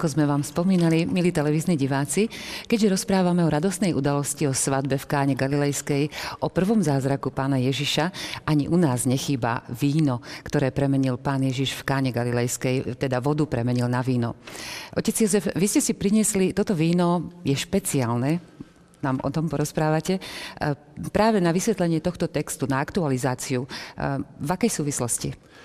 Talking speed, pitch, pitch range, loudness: 145 wpm, 145 Hz, 135-175 Hz, -24 LUFS